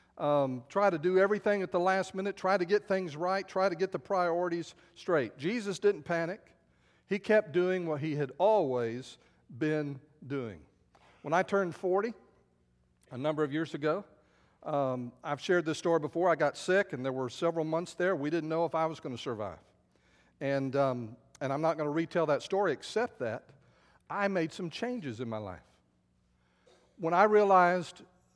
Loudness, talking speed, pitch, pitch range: -31 LUFS, 185 wpm, 160 Hz, 130-185 Hz